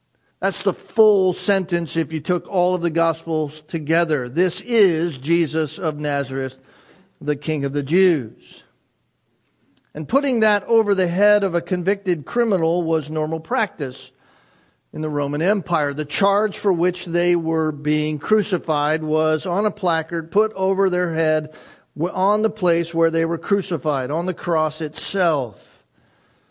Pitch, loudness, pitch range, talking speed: 170 Hz, -20 LUFS, 155-195 Hz, 150 wpm